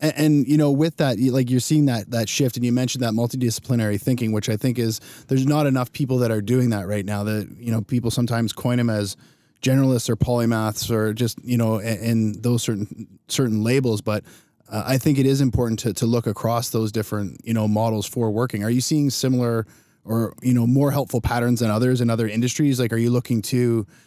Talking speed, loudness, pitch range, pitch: 225 wpm, -21 LUFS, 110-130 Hz, 120 Hz